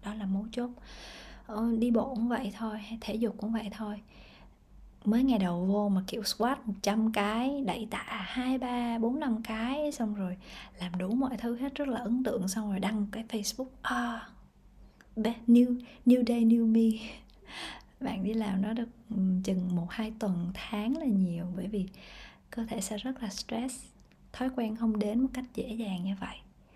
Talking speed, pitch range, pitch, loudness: 185 wpm, 205-240 Hz, 225 Hz, -31 LUFS